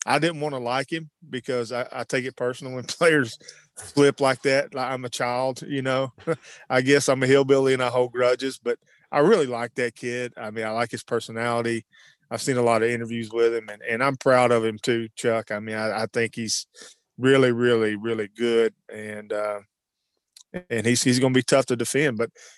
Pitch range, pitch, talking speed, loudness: 115-130 Hz, 125 Hz, 220 wpm, -23 LUFS